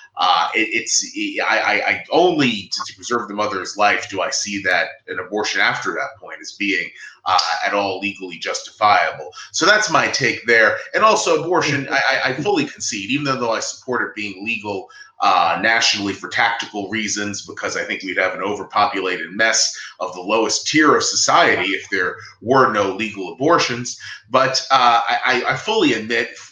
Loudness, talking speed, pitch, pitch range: -18 LUFS, 175 wpm, 110 Hz, 100-170 Hz